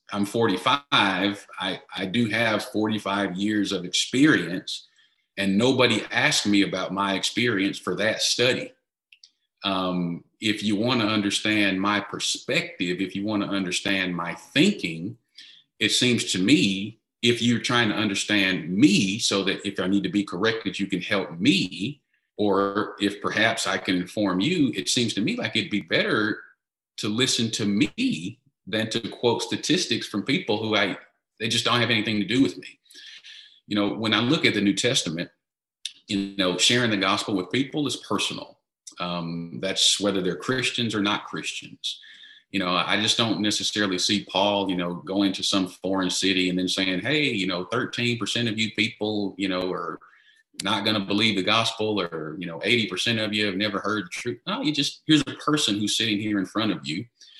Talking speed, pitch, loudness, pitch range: 185 wpm, 105 Hz, -24 LUFS, 95-115 Hz